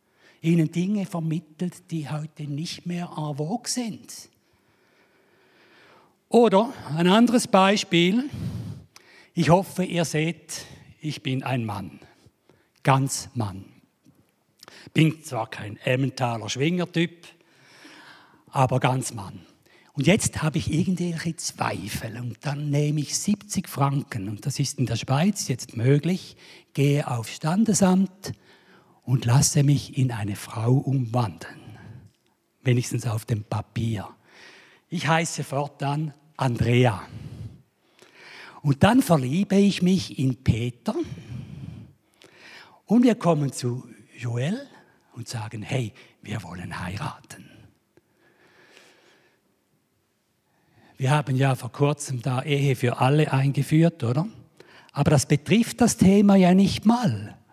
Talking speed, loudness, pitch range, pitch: 110 wpm, -24 LUFS, 125-175 Hz, 145 Hz